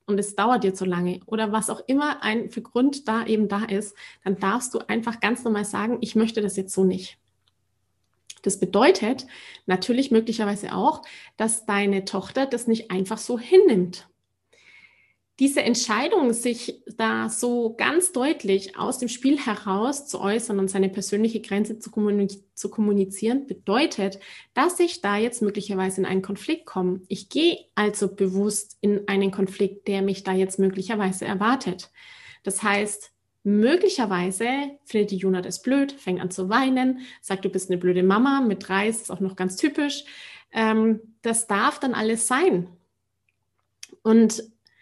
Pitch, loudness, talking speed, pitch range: 210 Hz, -24 LUFS, 160 wpm, 195-235 Hz